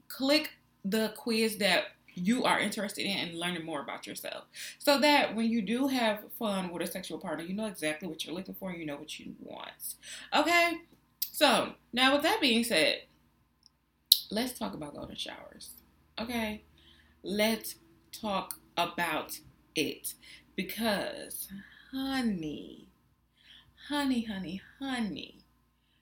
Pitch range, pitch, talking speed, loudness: 185-245 Hz, 215 Hz, 135 wpm, -31 LUFS